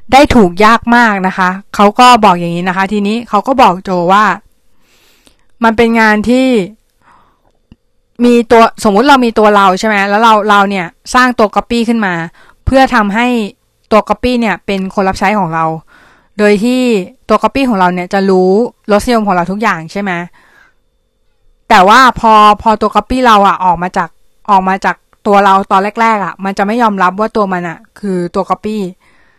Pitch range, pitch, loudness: 190-230 Hz, 210 Hz, -9 LUFS